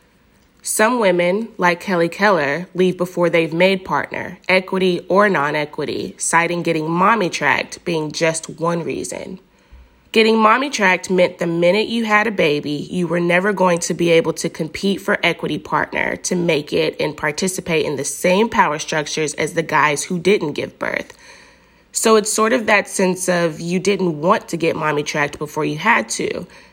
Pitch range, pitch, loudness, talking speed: 160-200 Hz, 175 Hz, -17 LUFS, 175 wpm